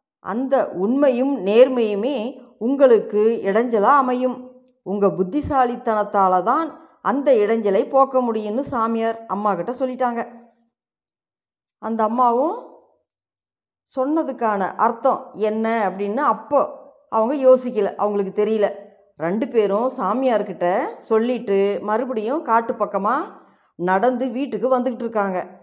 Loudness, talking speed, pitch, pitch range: -20 LUFS, 90 wpm, 230 Hz, 205-260 Hz